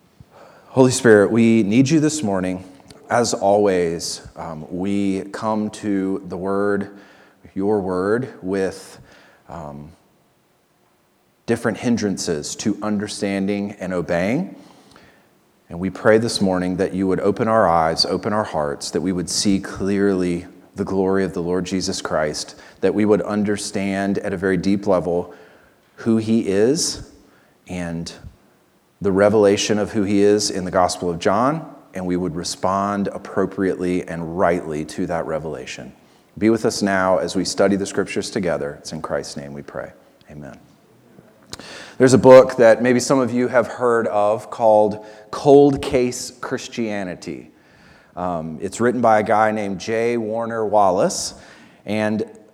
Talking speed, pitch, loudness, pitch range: 145 wpm, 100 Hz, -19 LUFS, 95-110 Hz